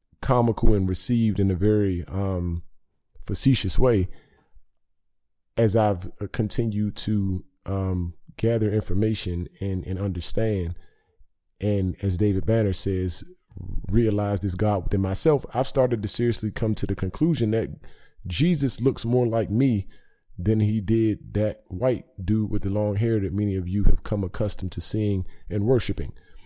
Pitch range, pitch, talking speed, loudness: 95-110 Hz, 105 Hz, 145 wpm, -25 LUFS